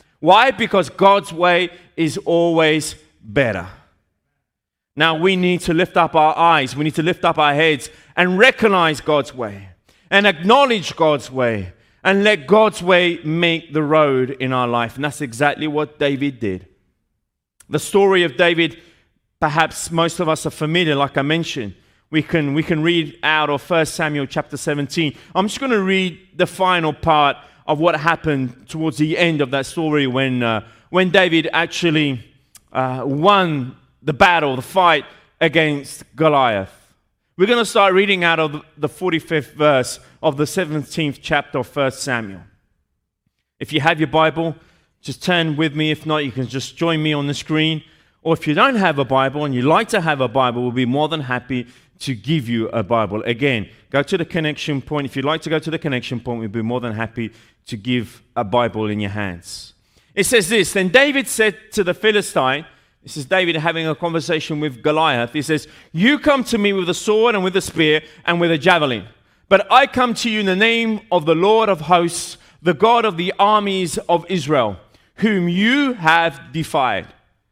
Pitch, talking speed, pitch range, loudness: 155 Hz, 190 wpm, 135-180 Hz, -17 LUFS